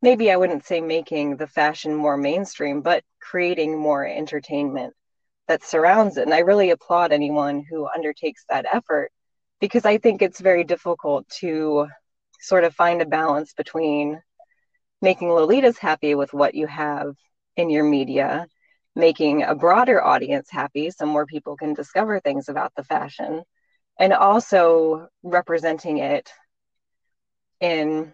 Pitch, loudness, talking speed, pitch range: 160 Hz, -21 LUFS, 145 wpm, 150-185 Hz